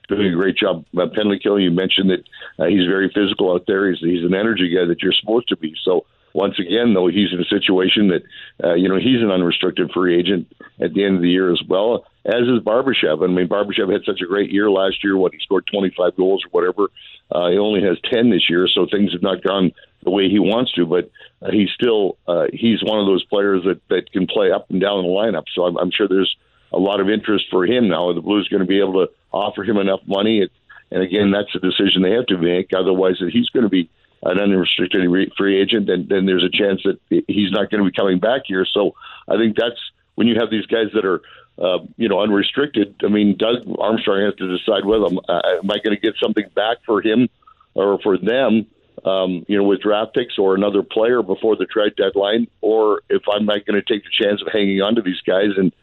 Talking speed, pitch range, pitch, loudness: 250 wpm, 90-105 Hz, 100 Hz, -18 LUFS